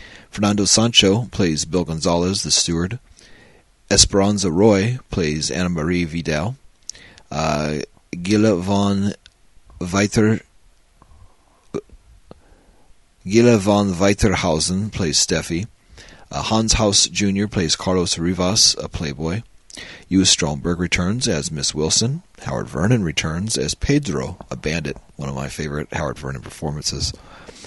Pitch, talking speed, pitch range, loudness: 95 Hz, 110 wpm, 80-105 Hz, -19 LUFS